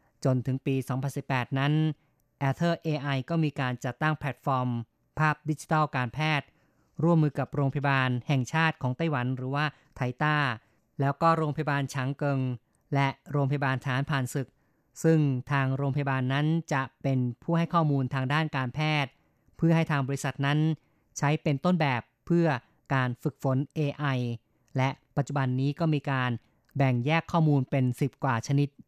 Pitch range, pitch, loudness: 130-155 Hz, 140 Hz, -28 LUFS